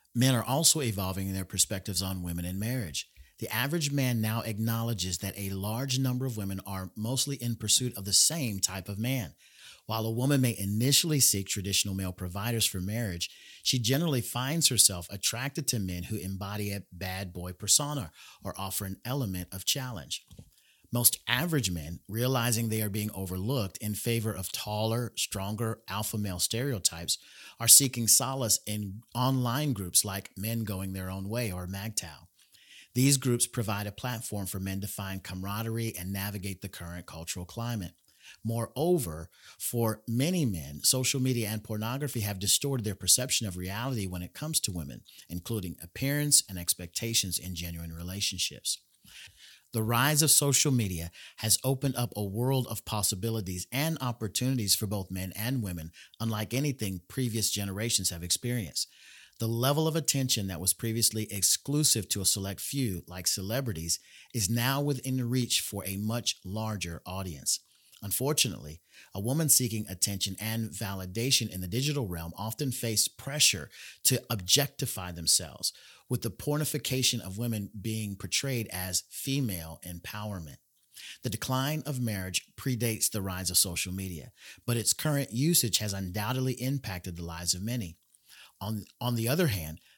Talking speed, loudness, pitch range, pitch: 155 wpm, -29 LUFS, 95-125 Hz, 110 Hz